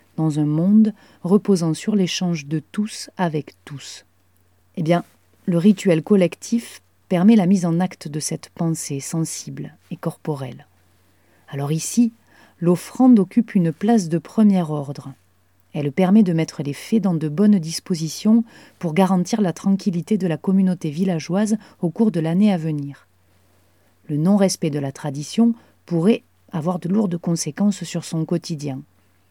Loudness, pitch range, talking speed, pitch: -20 LUFS, 150-195 Hz, 145 wpm, 170 Hz